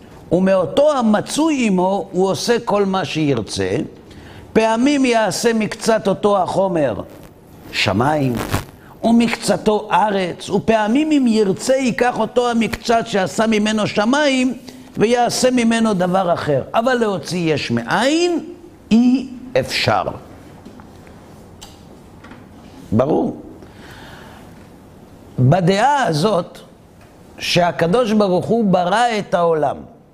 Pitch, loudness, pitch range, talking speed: 210 Hz, -17 LUFS, 175-235 Hz, 90 wpm